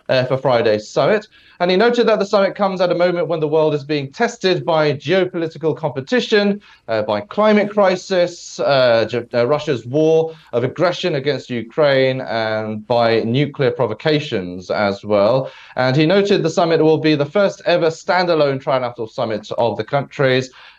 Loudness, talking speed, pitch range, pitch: -17 LUFS, 165 wpm, 130-180 Hz, 155 Hz